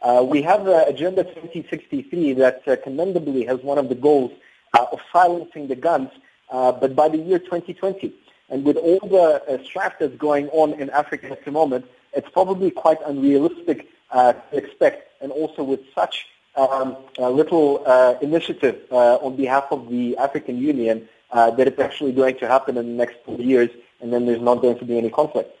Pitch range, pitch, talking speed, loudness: 125-160 Hz, 140 Hz, 195 wpm, -20 LUFS